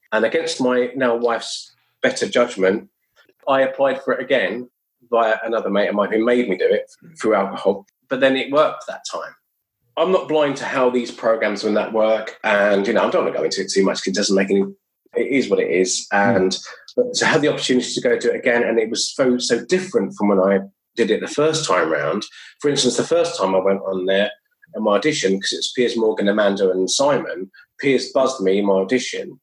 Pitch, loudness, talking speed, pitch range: 120 Hz, -19 LUFS, 230 wpm, 100-140 Hz